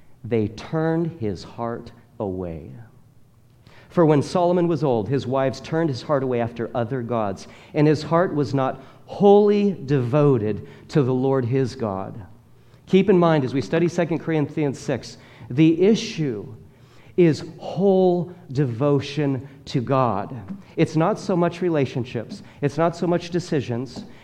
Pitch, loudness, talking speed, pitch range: 140 Hz, -22 LUFS, 140 wpm, 120-165 Hz